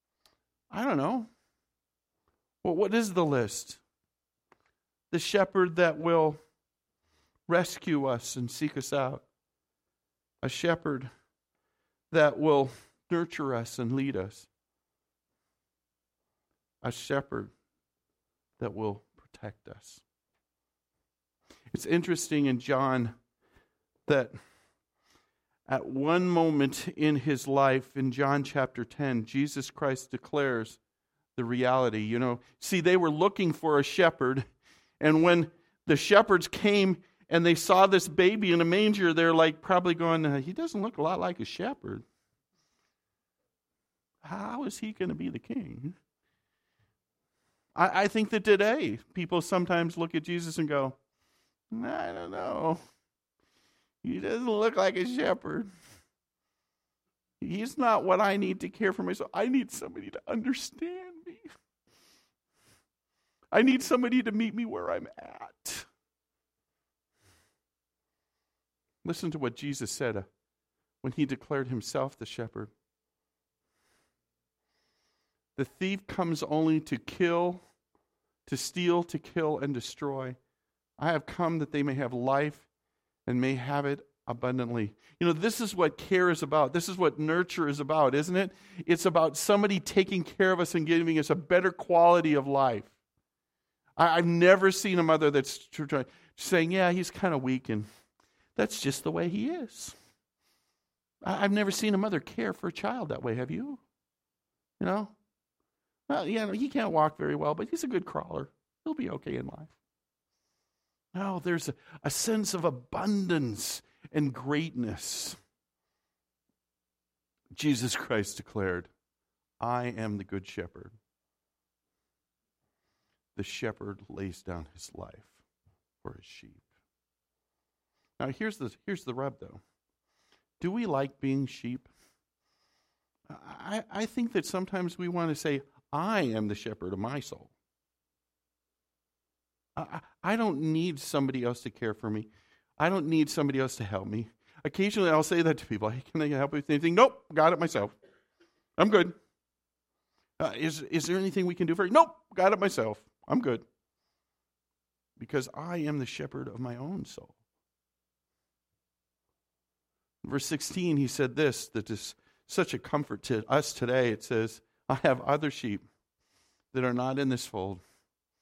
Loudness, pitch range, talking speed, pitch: -29 LUFS, 110-175 Hz, 145 wpm, 145 Hz